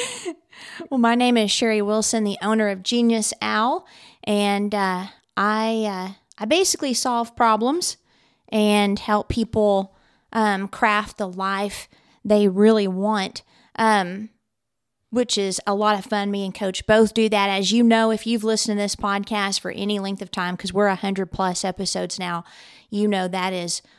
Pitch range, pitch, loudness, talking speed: 195-225 Hz, 205 Hz, -21 LUFS, 170 wpm